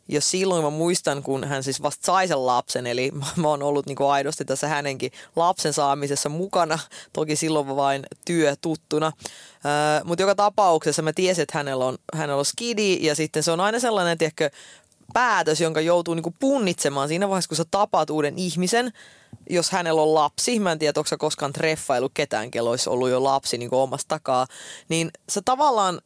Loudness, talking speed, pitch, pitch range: -23 LUFS, 195 wpm, 155 Hz, 140-175 Hz